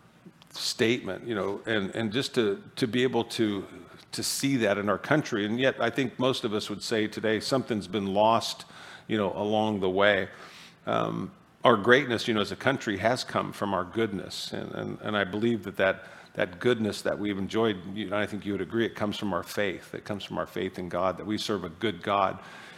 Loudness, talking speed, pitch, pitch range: -28 LUFS, 225 wpm, 105 Hz, 100-115 Hz